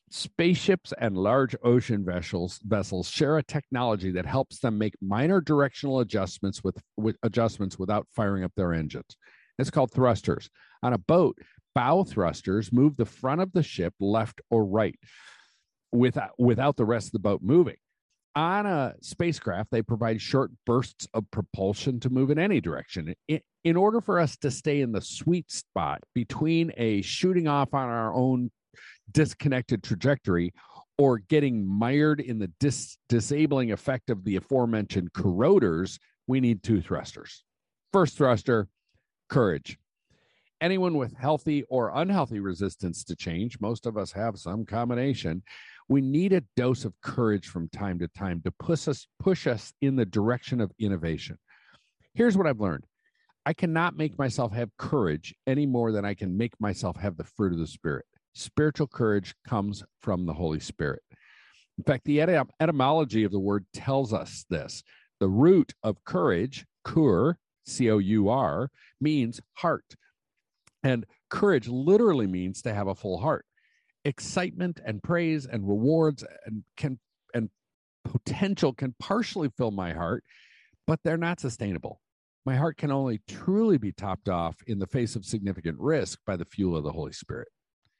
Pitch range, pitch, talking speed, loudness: 100-145 Hz, 120 Hz, 160 wpm, -27 LUFS